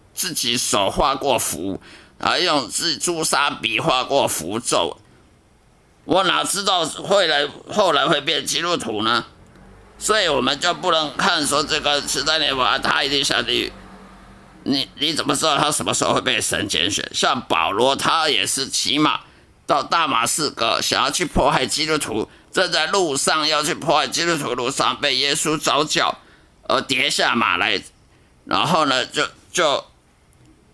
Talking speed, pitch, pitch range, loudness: 230 characters per minute, 145 Hz, 125-155 Hz, -19 LUFS